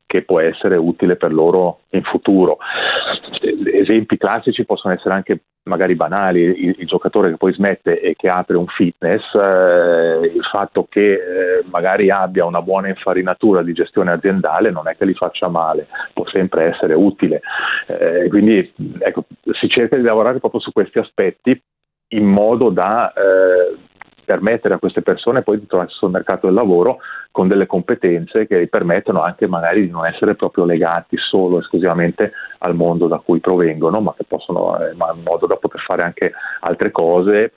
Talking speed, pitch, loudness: 175 wpm, 100 Hz, -16 LUFS